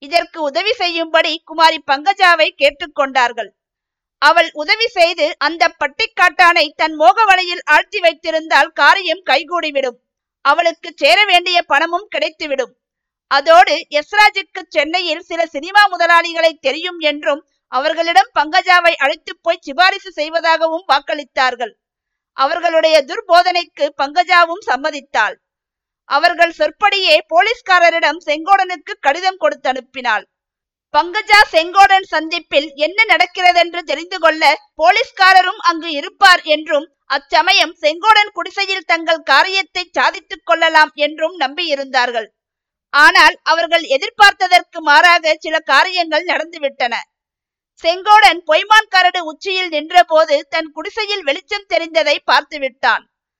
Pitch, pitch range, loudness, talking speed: 330 Hz, 295-360 Hz, -13 LUFS, 100 wpm